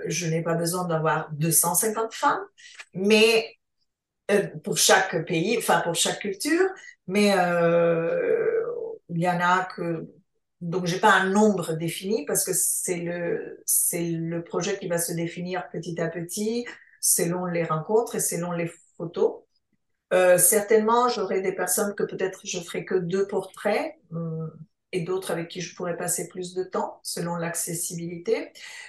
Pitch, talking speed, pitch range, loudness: 185 Hz, 155 wpm, 170-215 Hz, -24 LUFS